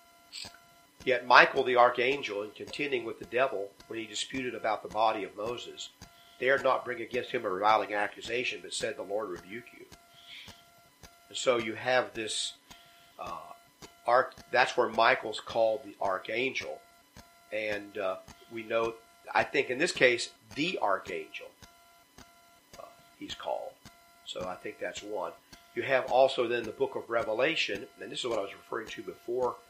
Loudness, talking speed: -30 LUFS, 160 wpm